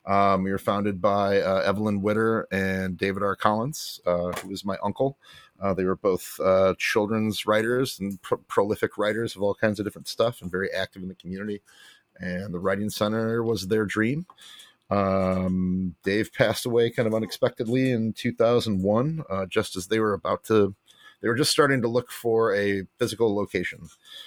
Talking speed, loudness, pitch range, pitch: 180 wpm, -25 LUFS, 95-115 Hz, 105 Hz